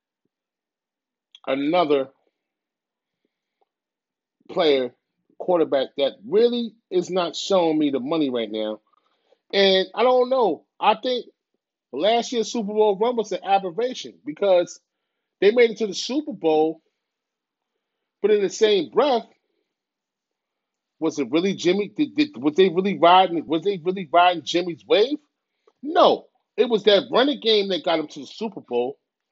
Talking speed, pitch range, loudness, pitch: 140 wpm, 165-245 Hz, -21 LUFS, 195 Hz